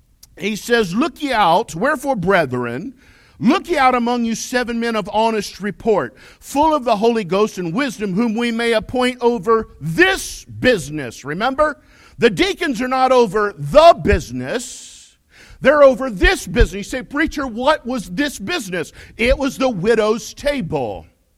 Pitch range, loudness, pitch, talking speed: 210-270 Hz, -17 LUFS, 235 Hz, 155 wpm